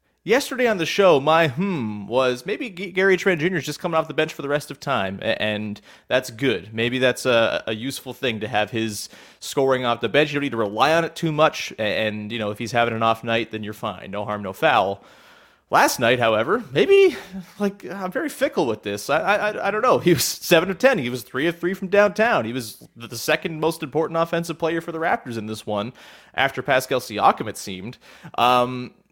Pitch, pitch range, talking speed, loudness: 145 Hz, 115-180 Hz, 225 wpm, -21 LUFS